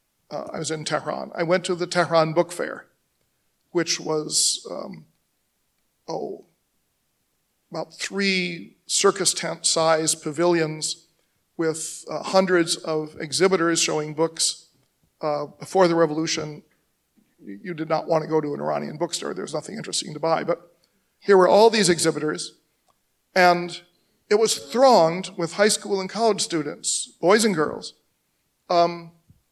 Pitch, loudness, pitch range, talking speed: 170 Hz, -22 LUFS, 160-180 Hz, 140 wpm